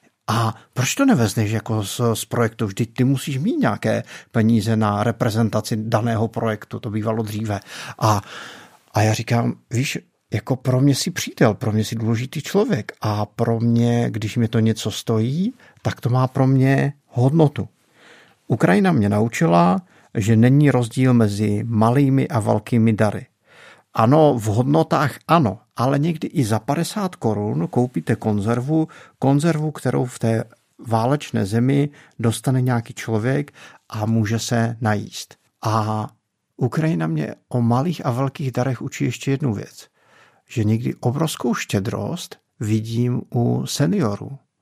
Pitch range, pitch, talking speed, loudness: 110-135 Hz, 120 Hz, 140 wpm, -20 LUFS